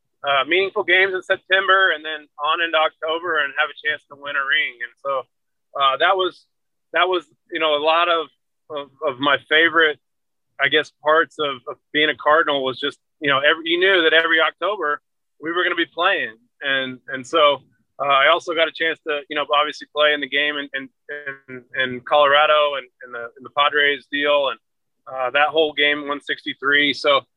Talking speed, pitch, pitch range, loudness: 205 wpm, 150 Hz, 140-165 Hz, -19 LUFS